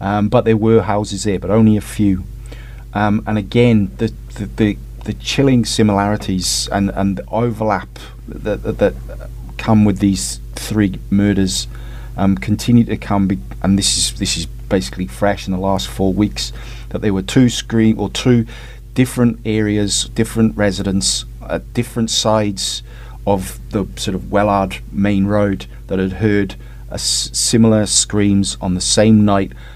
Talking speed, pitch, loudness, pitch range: 160 wpm, 105 Hz, -16 LUFS, 100-115 Hz